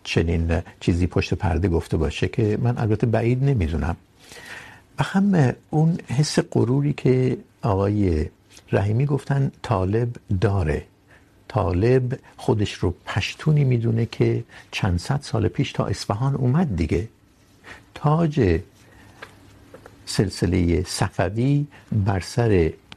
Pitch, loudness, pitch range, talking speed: 110 Hz, -22 LUFS, 95-130 Hz, 105 wpm